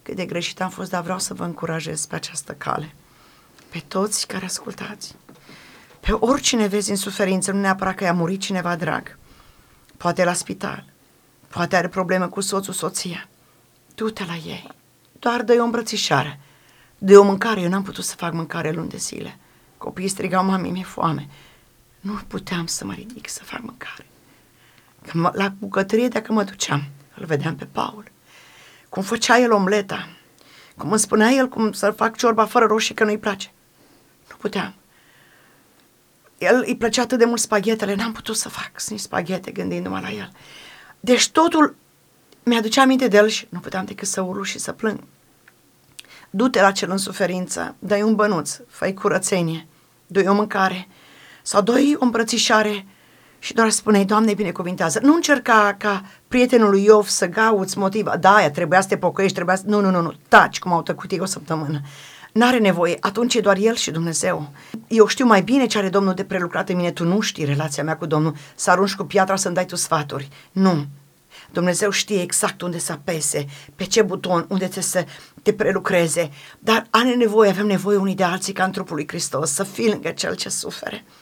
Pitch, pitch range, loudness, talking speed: 195 Hz, 175-215 Hz, -20 LUFS, 180 wpm